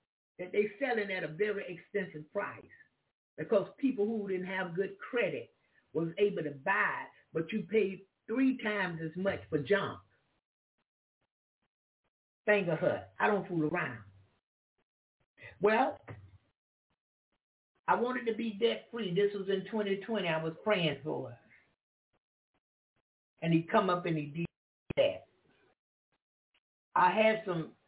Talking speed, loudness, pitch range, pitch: 135 wpm, -33 LUFS, 160-210 Hz, 195 Hz